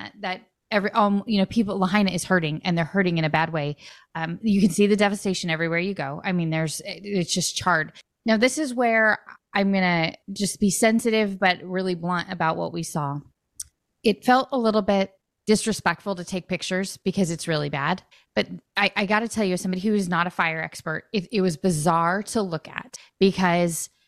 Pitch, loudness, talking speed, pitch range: 185 Hz, -23 LUFS, 205 wpm, 170-205 Hz